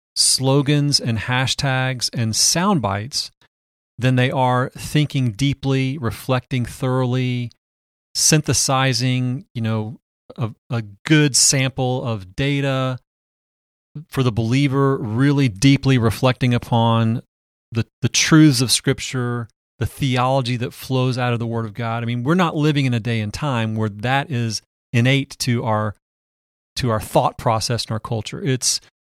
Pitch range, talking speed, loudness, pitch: 115-135 Hz, 140 wpm, -19 LUFS, 125 Hz